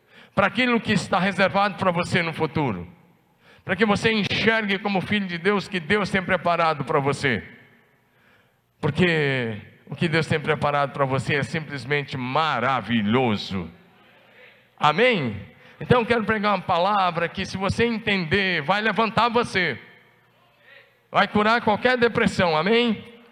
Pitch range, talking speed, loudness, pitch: 155-210 Hz, 135 wpm, -22 LUFS, 185 Hz